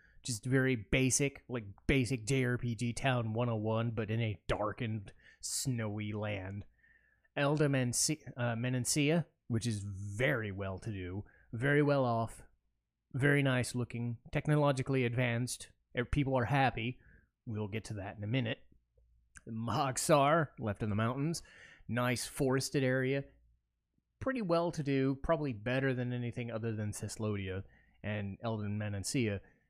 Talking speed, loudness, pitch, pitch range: 130 wpm, -34 LUFS, 120 Hz, 105-130 Hz